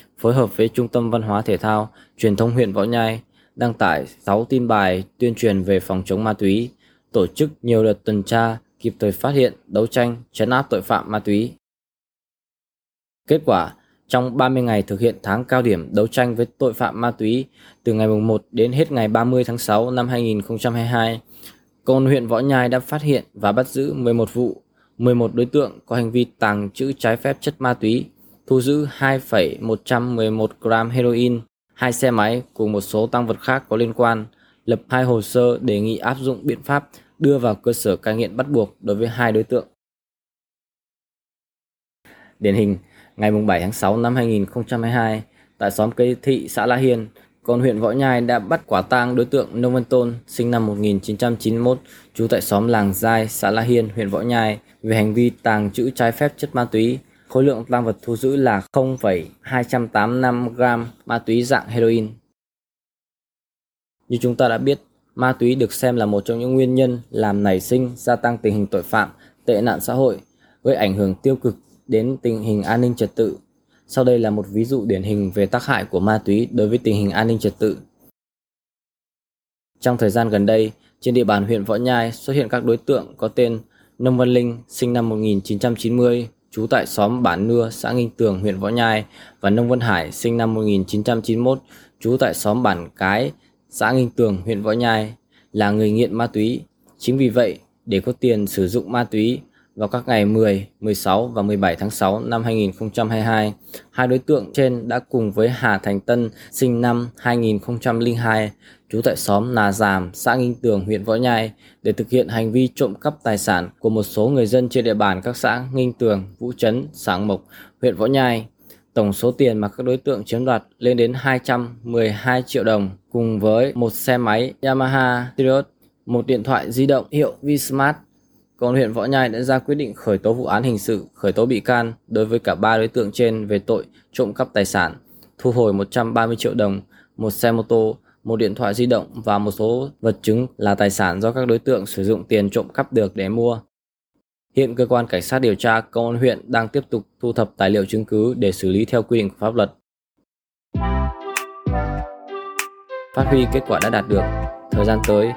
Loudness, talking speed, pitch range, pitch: -19 LUFS, 205 wpm, 110-125 Hz, 115 Hz